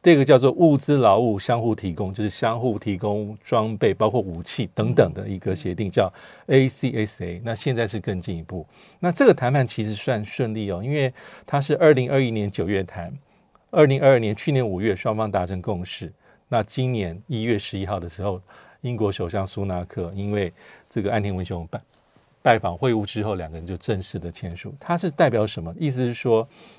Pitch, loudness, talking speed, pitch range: 110 Hz, -23 LUFS, 300 characters per minute, 95-130 Hz